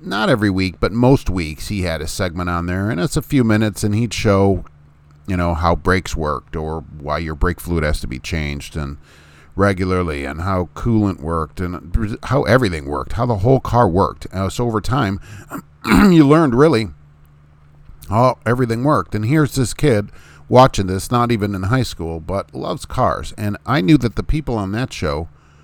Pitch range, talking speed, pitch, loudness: 80-115 Hz, 190 wpm, 95 Hz, -18 LUFS